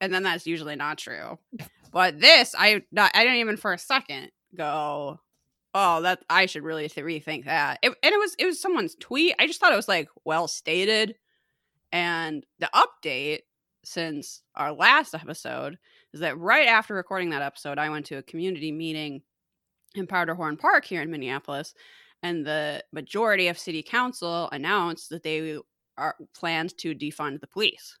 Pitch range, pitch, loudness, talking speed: 150-205 Hz, 170 Hz, -24 LUFS, 175 wpm